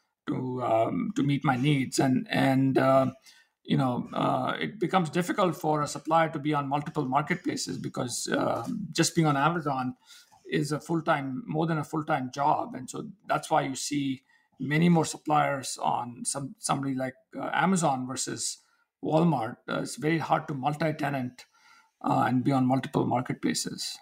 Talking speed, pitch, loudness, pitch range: 165 wpm, 150 Hz, -28 LUFS, 135-165 Hz